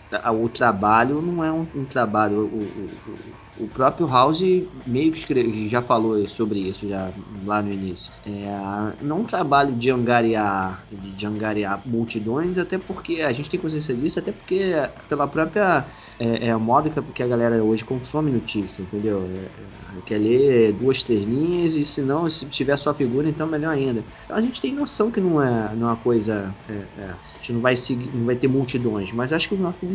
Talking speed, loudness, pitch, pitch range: 200 wpm, -22 LUFS, 120 Hz, 105-150 Hz